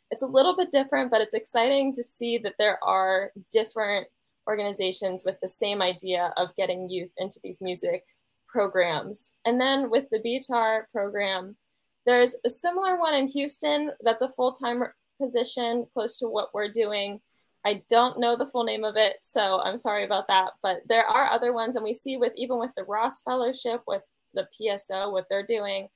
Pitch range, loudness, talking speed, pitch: 195-245 Hz, -26 LUFS, 185 wpm, 225 Hz